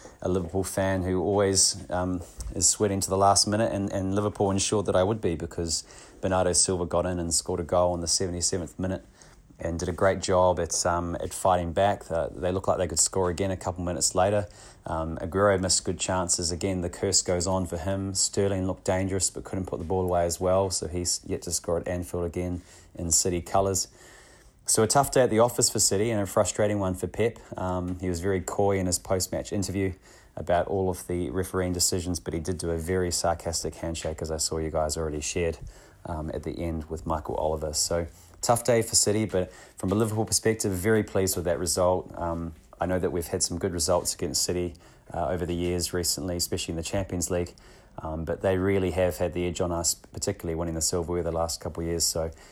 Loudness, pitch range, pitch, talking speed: -26 LUFS, 85-95 Hz, 90 Hz, 225 wpm